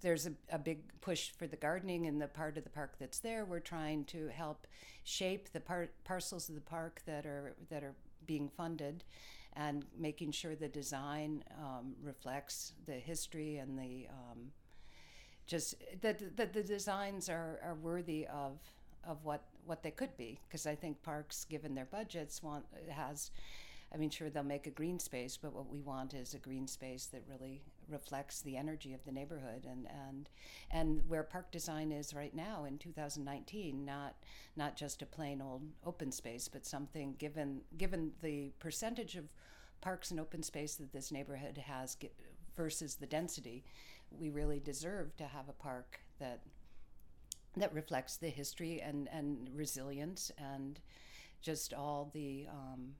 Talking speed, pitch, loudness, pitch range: 170 wpm, 150 Hz, -45 LUFS, 140-160 Hz